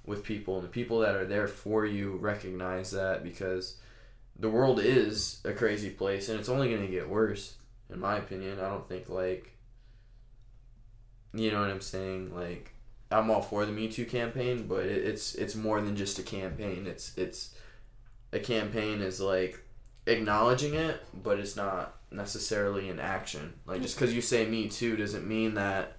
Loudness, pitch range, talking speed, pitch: -32 LUFS, 95-115 Hz, 180 wpm, 110 Hz